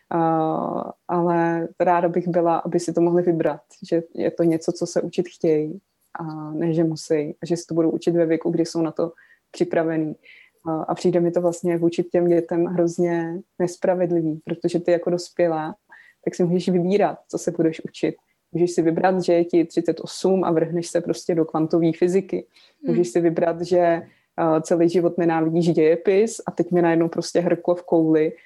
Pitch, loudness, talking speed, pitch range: 170 Hz, -22 LUFS, 190 wpm, 165-175 Hz